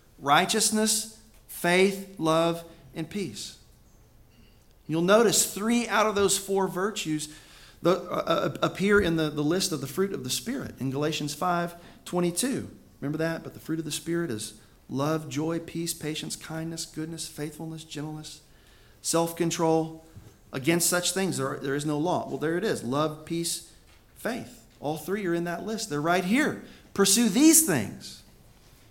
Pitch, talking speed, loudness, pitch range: 165 Hz, 160 wpm, -27 LUFS, 150-190 Hz